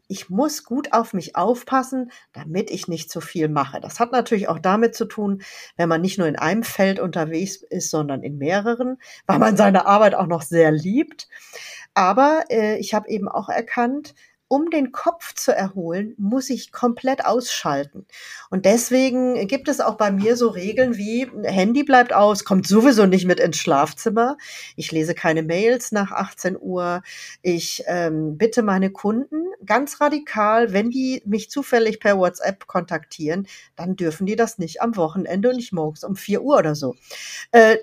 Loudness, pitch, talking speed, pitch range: -20 LUFS, 210 Hz, 175 wpm, 175-240 Hz